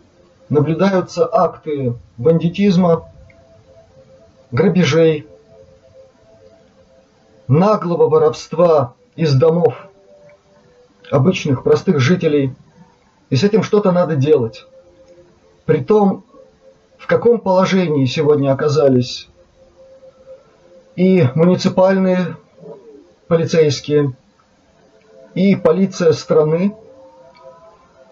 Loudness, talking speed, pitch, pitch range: -15 LUFS, 65 wpm, 160 Hz, 130-185 Hz